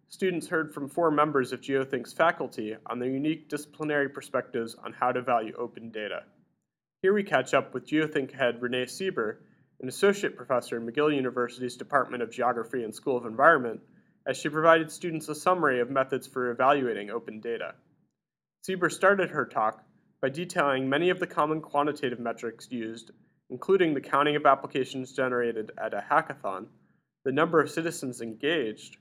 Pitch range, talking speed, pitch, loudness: 125-160 Hz, 165 wpm, 140 Hz, -28 LUFS